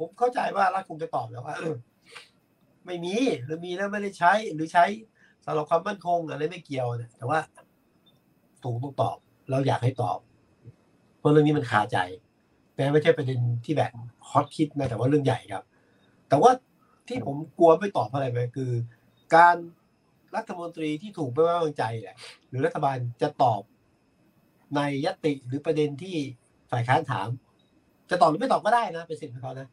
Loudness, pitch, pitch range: -26 LUFS, 150 Hz, 125-170 Hz